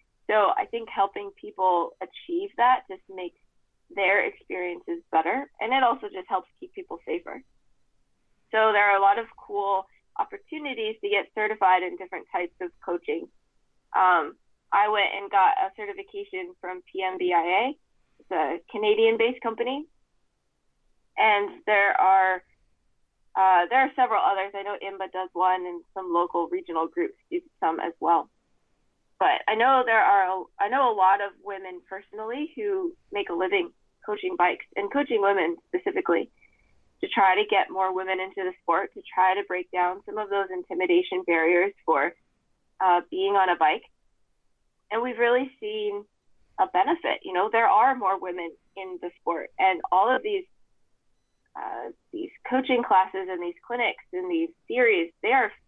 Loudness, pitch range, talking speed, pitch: -25 LUFS, 185-310 Hz, 160 wpm, 205 Hz